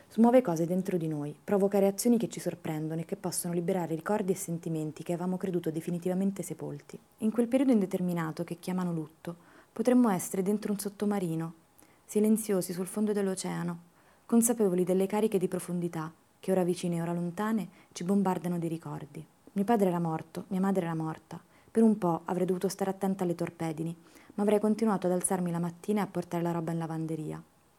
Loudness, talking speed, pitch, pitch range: -30 LUFS, 180 wpm, 180 Hz, 170-200 Hz